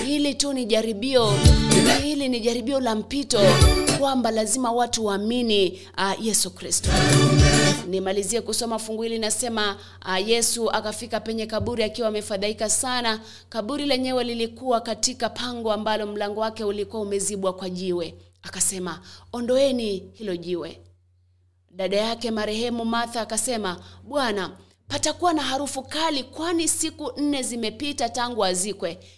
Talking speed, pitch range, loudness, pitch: 120 wpm, 200-245 Hz, -23 LUFS, 225 Hz